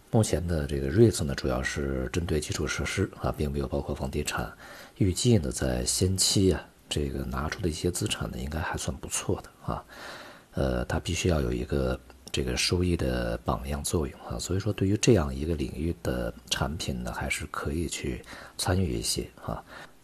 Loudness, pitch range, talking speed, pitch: -29 LUFS, 70-90 Hz, 290 characters per minute, 80 Hz